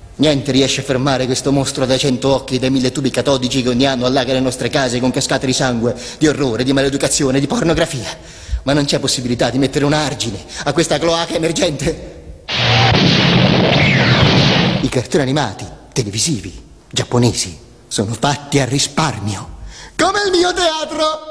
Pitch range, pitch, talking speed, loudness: 125-150 Hz, 135 Hz, 160 wpm, -15 LUFS